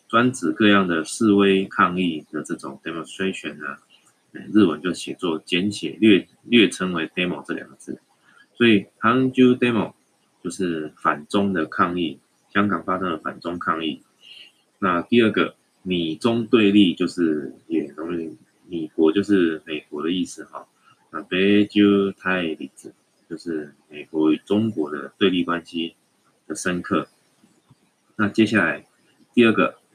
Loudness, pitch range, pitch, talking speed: -21 LUFS, 85-105 Hz, 95 Hz, 255 characters per minute